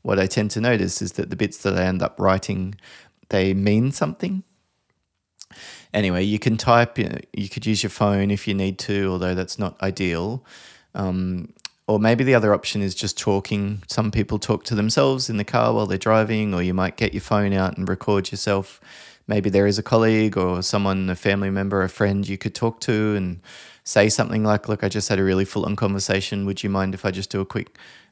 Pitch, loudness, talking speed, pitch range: 100 Hz, -22 LUFS, 220 wpm, 95-110 Hz